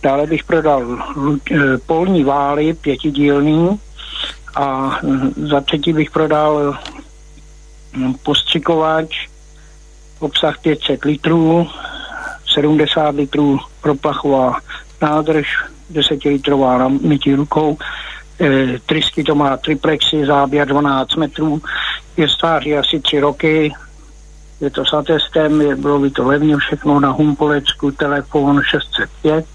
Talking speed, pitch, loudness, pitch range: 105 wpm, 150 Hz, -15 LUFS, 140-155 Hz